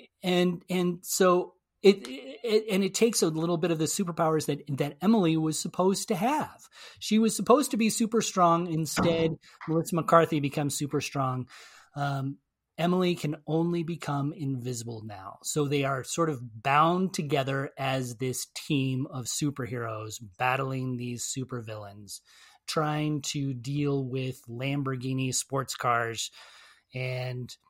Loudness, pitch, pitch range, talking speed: -28 LUFS, 145 Hz, 130-175 Hz, 140 wpm